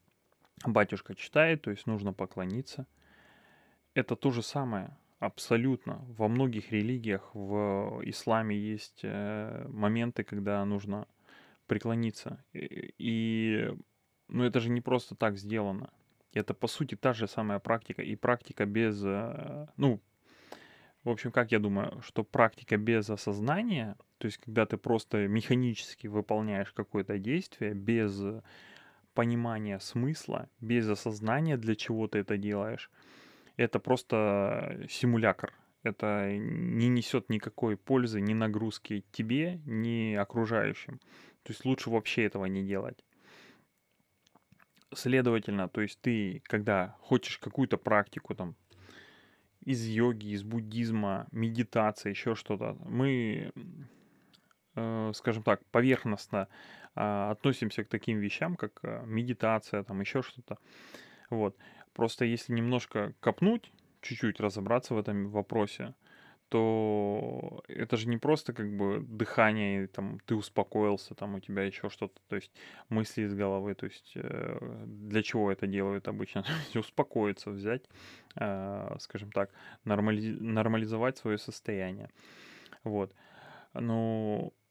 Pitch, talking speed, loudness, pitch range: 110 Hz, 120 wpm, -33 LUFS, 105-120 Hz